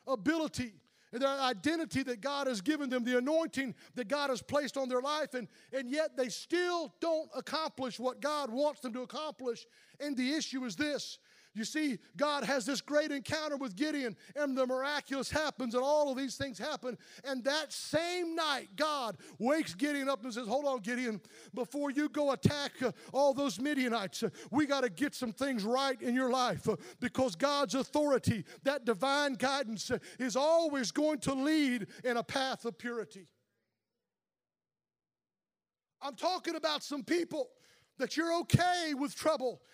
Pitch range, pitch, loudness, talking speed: 250-295 Hz, 270 Hz, -34 LUFS, 175 wpm